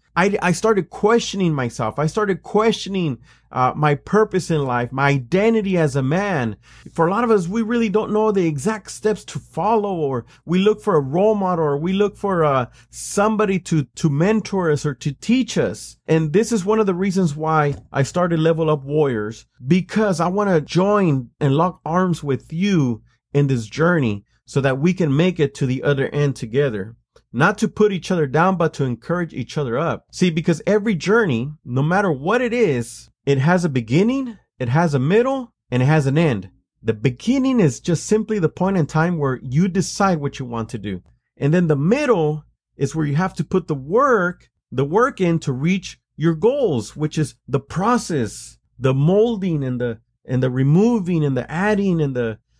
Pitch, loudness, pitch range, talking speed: 160 Hz, -19 LUFS, 135-195 Hz, 200 wpm